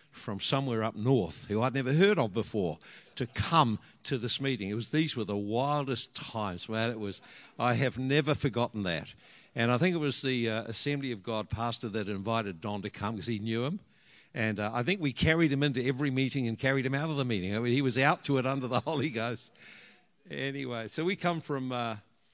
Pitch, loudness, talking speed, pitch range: 125 Hz, -31 LUFS, 225 wpm, 110-140 Hz